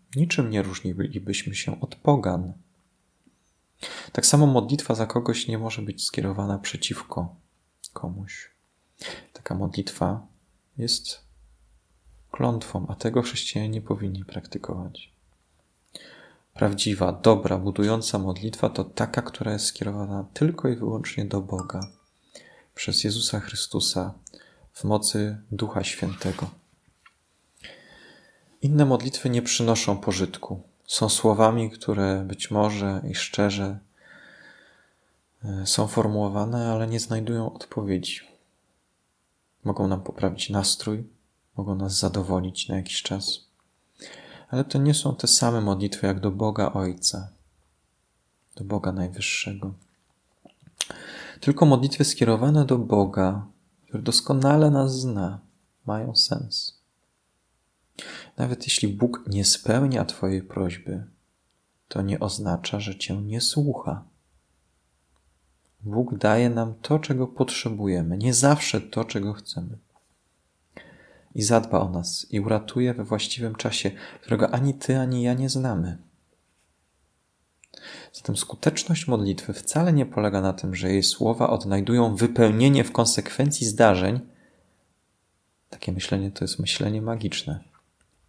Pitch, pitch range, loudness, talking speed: 105 Hz, 95-120 Hz, -24 LUFS, 110 wpm